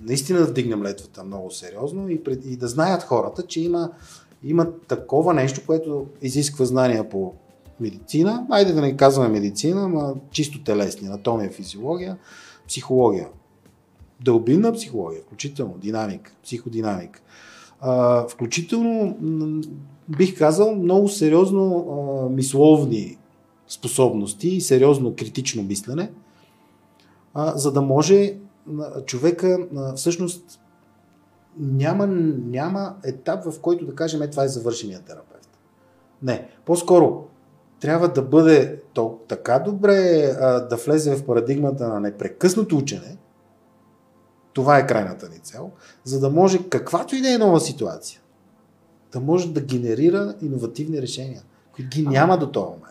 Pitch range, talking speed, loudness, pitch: 120-170 Hz, 120 wpm, -21 LUFS, 145 Hz